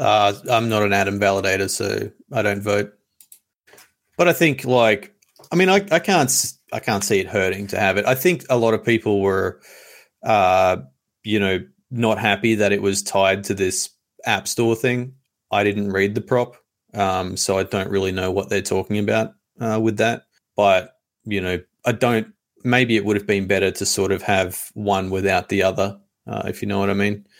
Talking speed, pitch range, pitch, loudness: 200 wpm, 95-115 Hz, 100 Hz, -20 LUFS